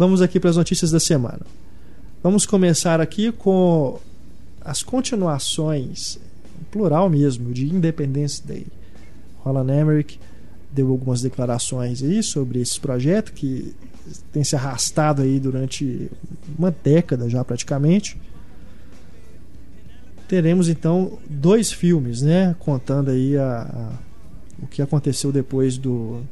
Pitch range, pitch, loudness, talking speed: 125-170 Hz, 140 Hz, -20 LUFS, 115 wpm